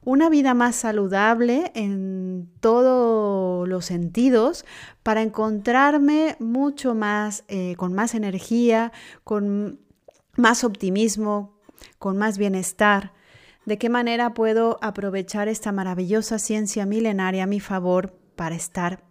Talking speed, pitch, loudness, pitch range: 115 wpm, 215 Hz, -22 LUFS, 195-235 Hz